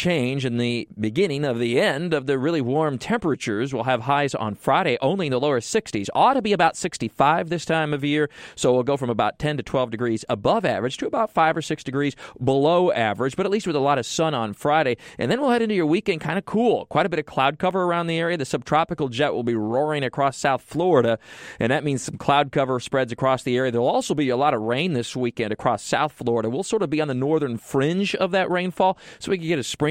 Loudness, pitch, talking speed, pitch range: -22 LUFS, 145 Hz, 255 wpm, 125-170 Hz